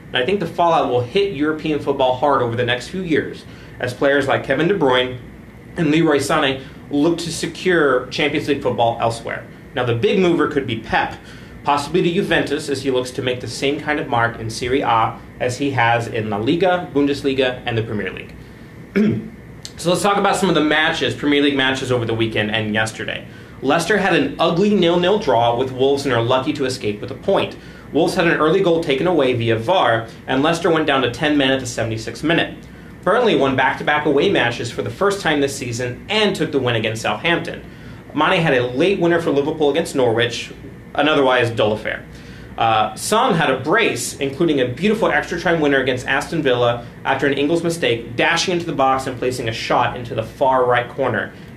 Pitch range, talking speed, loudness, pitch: 125-160 Hz, 205 wpm, -18 LUFS, 140 Hz